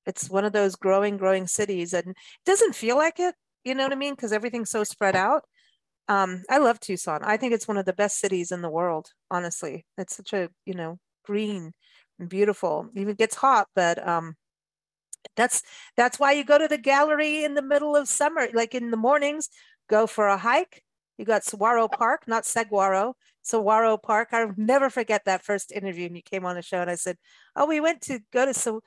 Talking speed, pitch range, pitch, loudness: 215 wpm, 190-260 Hz, 215 Hz, -24 LUFS